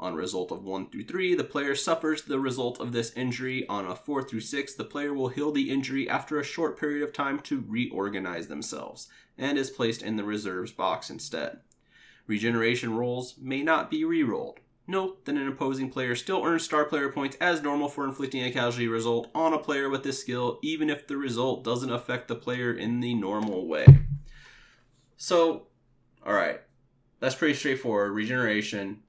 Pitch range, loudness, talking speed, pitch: 120-145 Hz, -28 LUFS, 185 wpm, 130 Hz